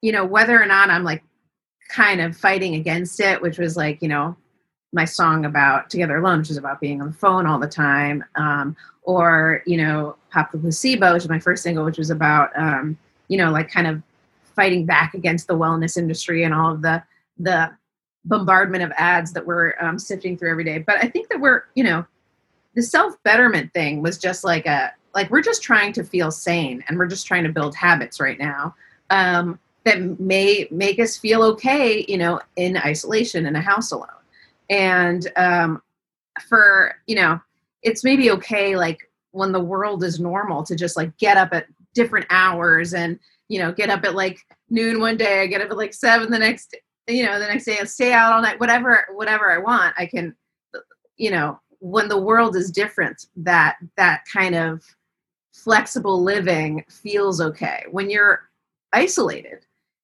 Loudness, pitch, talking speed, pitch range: -18 LUFS, 180 Hz, 195 wpm, 165-205 Hz